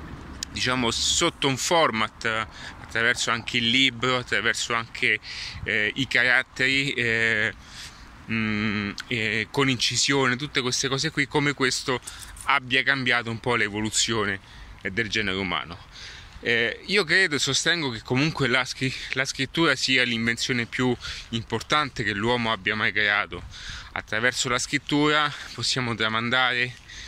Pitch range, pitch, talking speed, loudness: 110-135 Hz, 120 Hz, 130 wpm, -23 LUFS